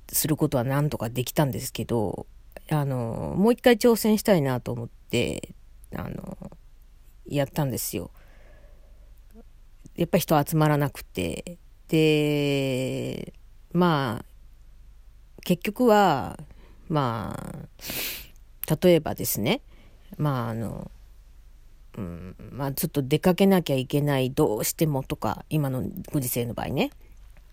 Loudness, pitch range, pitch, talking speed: -25 LUFS, 115-160 Hz, 140 Hz, 230 characters per minute